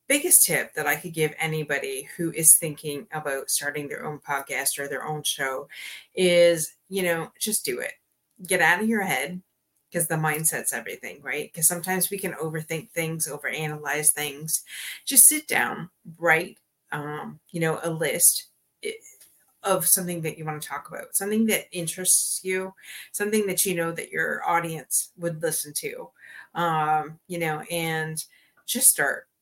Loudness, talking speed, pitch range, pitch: -23 LUFS, 165 wpm, 155-190 Hz, 165 Hz